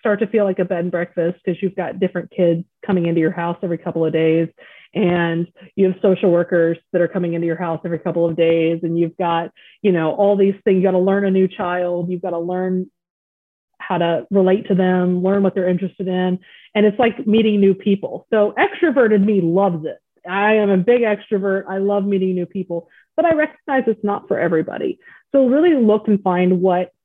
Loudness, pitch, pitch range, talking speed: -18 LUFS, 185 Hz, 170-200 Hz, 220 wpm